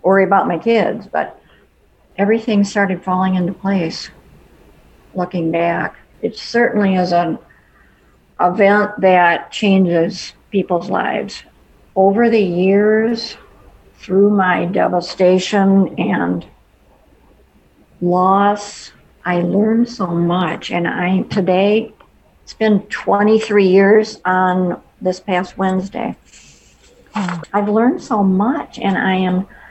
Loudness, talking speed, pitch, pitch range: -16 LUFS, 105 wpm, 190 Hz, 180-210 Hz